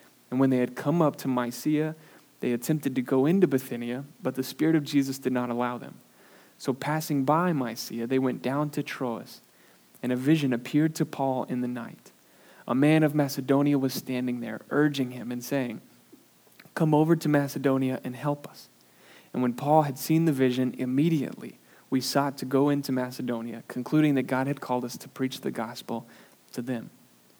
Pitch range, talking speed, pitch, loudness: 125-150 Hz, 185 wpm, 135 Hz, -27 LUFS